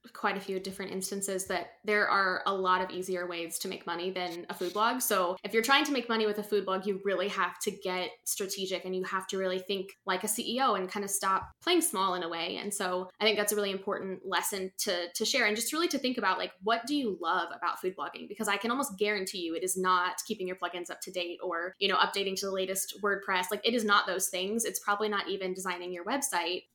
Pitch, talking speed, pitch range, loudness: 195 Hz, 260 wpm, 185-210 Hz, -31 LUFS